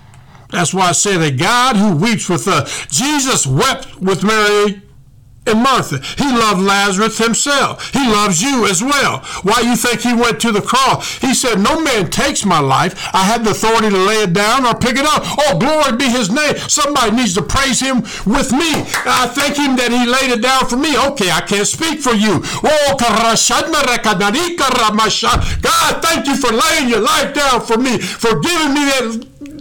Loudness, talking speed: -13 LUFS, 195 wpm